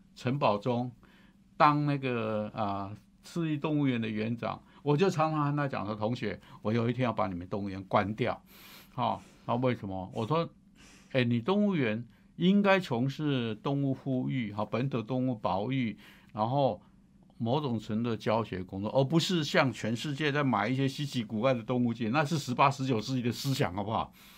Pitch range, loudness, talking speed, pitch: 110-150 Hz, -31 LUFS, 275 characters per minute, 130 Hz